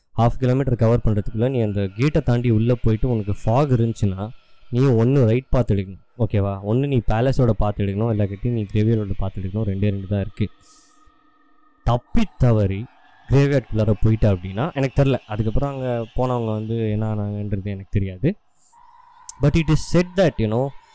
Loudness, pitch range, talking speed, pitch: -21 LUFS, 105-135 Hz, 160 wpm, 115 Hz